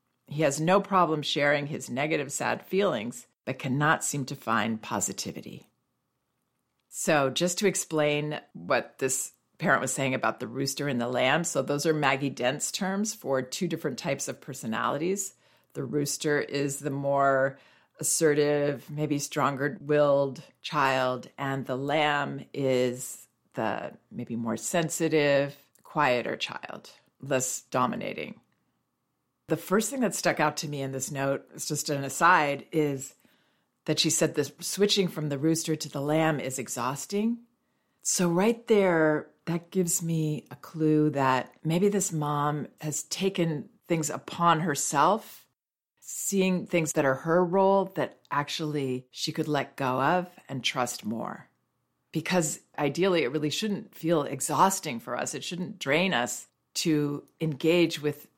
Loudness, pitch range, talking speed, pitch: -28 LUFS, 135-170 Hz, 145 wpm, 150 Hz